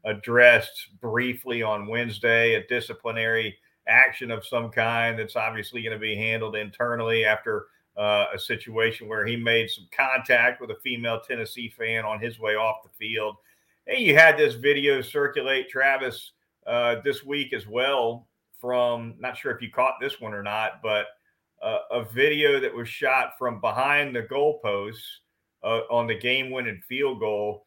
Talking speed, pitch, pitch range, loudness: 165 wpm, 115 Hz, 110-125 Hz, -24 LUFS